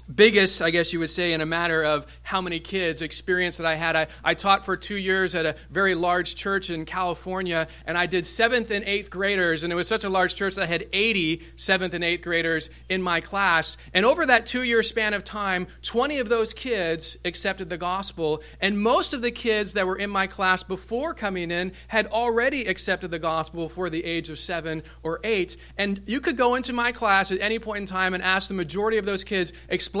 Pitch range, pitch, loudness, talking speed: 170-205 Hz, 185 Hz, -24 LUFS, 230 wpm